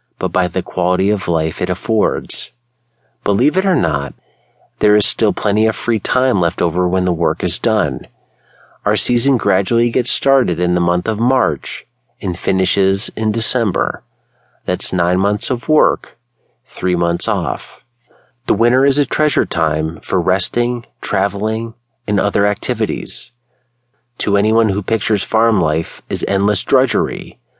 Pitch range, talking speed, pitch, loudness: 90-120 Hz, 150 wpm, 105 Hz, -16 LUFS